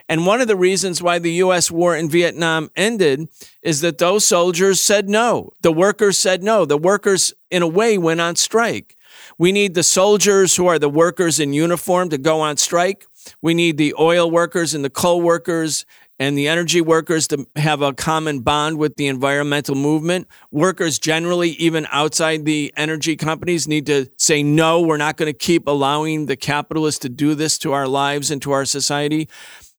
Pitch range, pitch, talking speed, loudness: 150-180 Hz, 165 Hz, 190 wpm, -17 LUFS